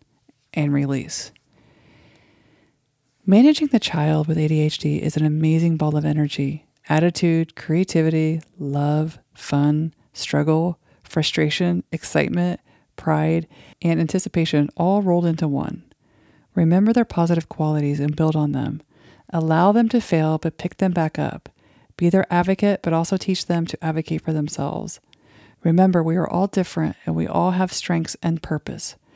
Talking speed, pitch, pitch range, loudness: 140 wpm, 160 Hz, 150-175 Hz, -21 LUFS